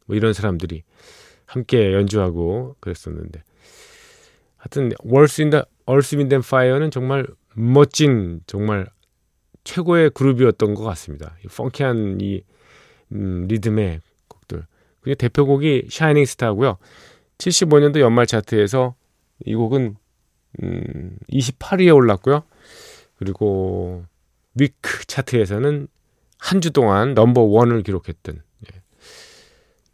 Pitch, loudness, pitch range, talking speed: 115 Hz, -18 LUFS, 95-140 Hz, 260 characters per minute